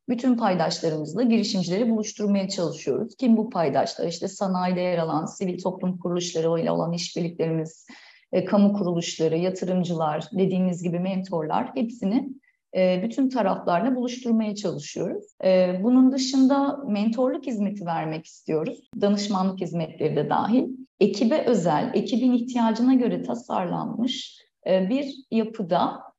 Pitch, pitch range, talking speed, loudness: 200 Hz, 180-245 Hz, 115 wpm, -24 LUFS